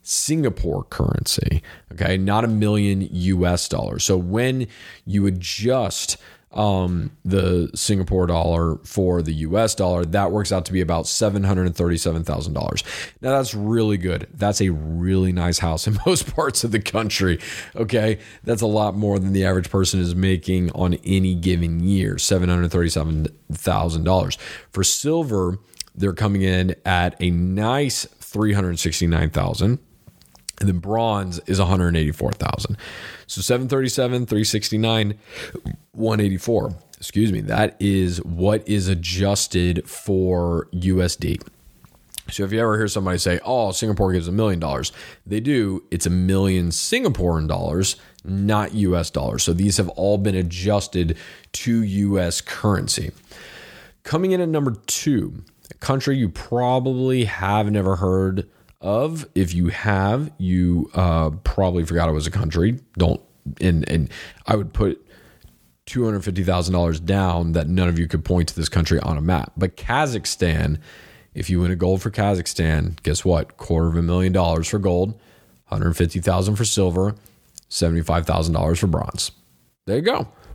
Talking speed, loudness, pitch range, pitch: 140 wpm, -21 LUFS, 85-105 Hz, 95 Hz